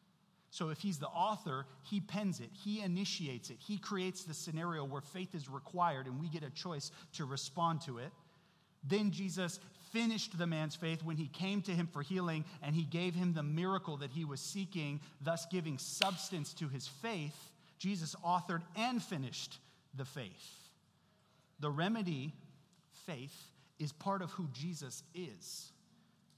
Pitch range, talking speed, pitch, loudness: 150-185 Hz, 165 wpm, 170 Hz, -40 LUFS